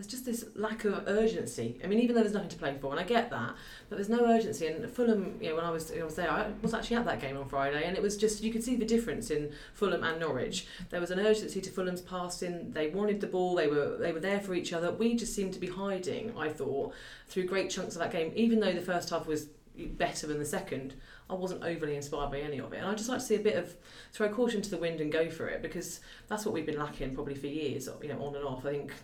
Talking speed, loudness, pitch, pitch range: 285 wpm, -33 LUFS, 180 Hz, 155-215 Hz